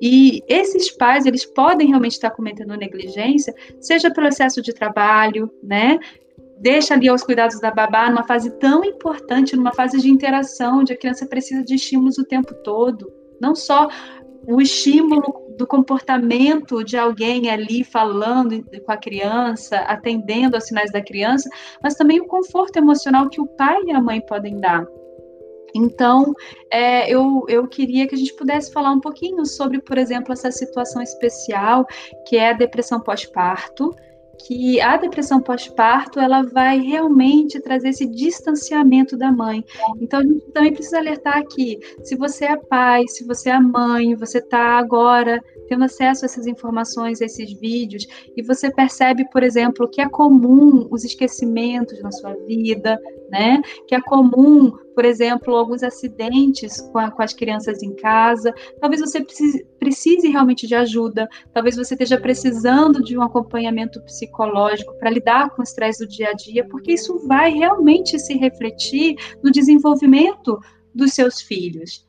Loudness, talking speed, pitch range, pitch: -17 LUFS, 160 wpm, 230-275 Hz, 255 Hz